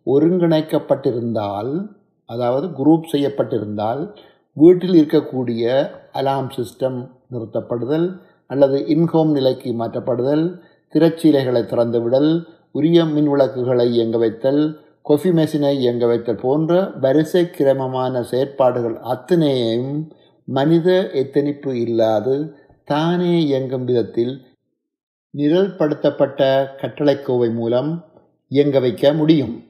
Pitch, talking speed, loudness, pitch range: 140 Hz, 80 wpm, -18 LUFS, 125-160 Hz